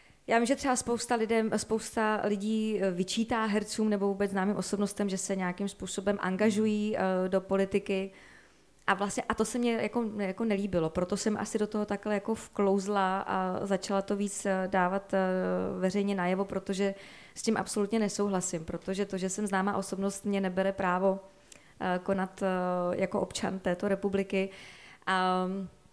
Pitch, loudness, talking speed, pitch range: 195 Hz, -31 LUFS, 160 wpm, 190-210 Hz